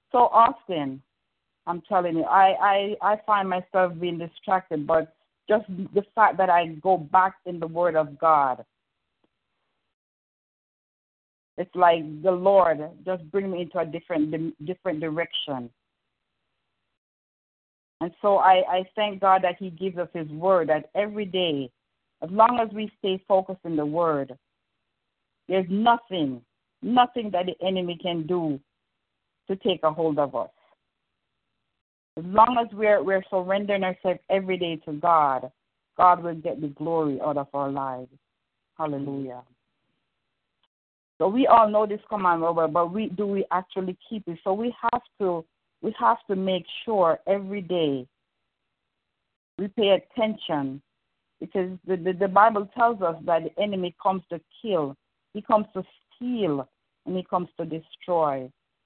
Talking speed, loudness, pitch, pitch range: 150 wpm, -24 LUFS, 180 Hz, 155-195 Hz